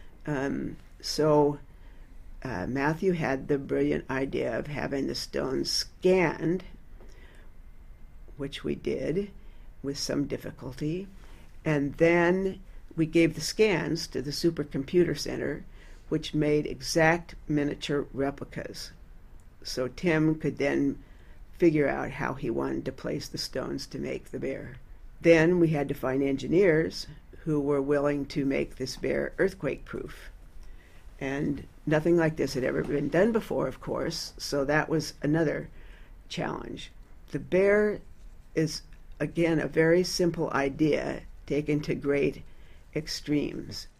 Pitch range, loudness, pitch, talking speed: 135-160 Hz, -28 LUFS, 145 Hz, 130 wpm